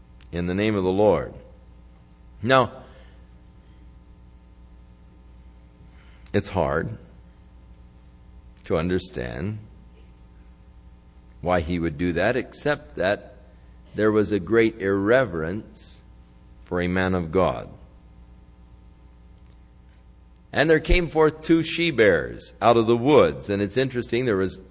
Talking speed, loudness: 105 wpm, -23 LUFS